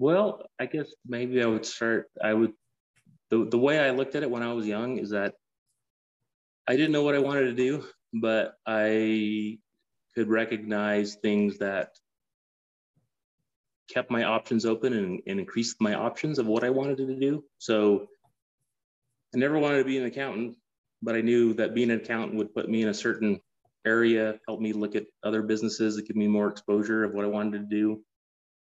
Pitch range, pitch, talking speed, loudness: 105-125 Hz, 110 Hz, 190 wpm, -27 LUFS